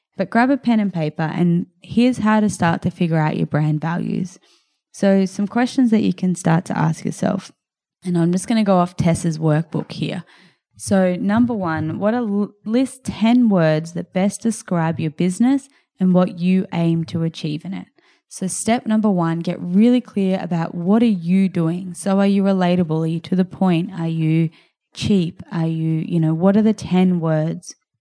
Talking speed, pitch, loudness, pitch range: 195 wpm, 185 Hz, -19 LUFS, 165-210 Hz